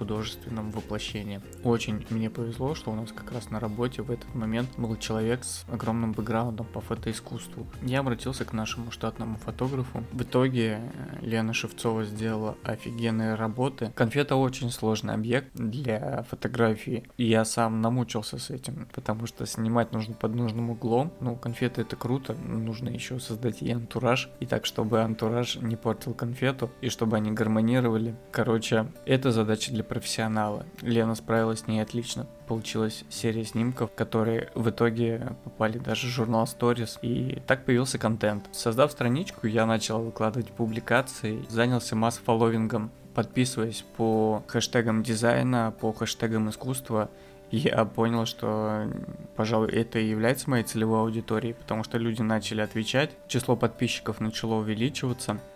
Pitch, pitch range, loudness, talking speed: 115 Hz, 110-120 Hz, -28 LUFS, 145 wpm